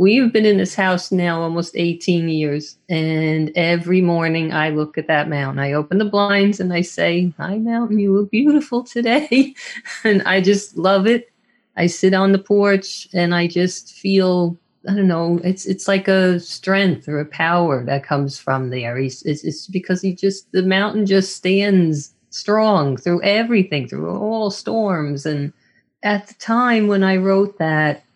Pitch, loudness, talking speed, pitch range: 185 Hz, -18 LUFS, 175 wpm, 160-200 Hz